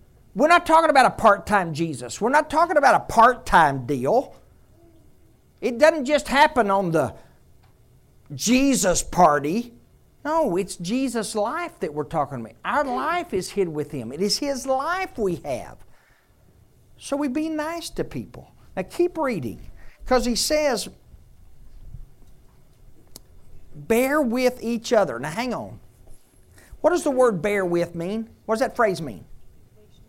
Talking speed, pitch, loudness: 150 wpm, 210 Hz, -22 LUFS